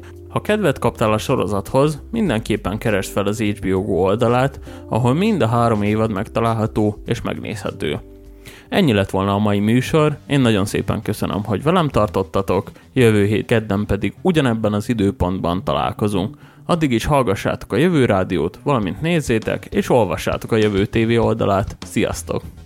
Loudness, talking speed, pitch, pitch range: -19 LUFS, 150 wpm, 110 Hz, 100-130 Hz